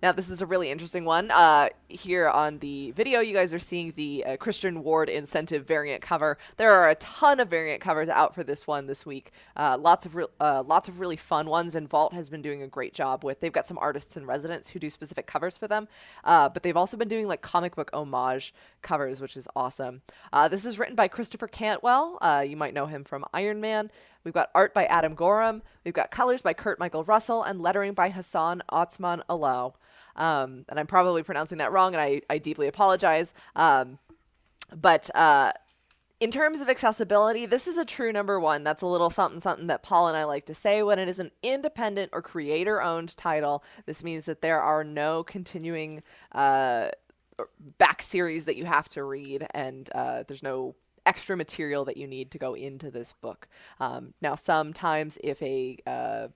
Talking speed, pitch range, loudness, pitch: 210 wpm, 150-195 Hz, -26 LUFS, 165 Hz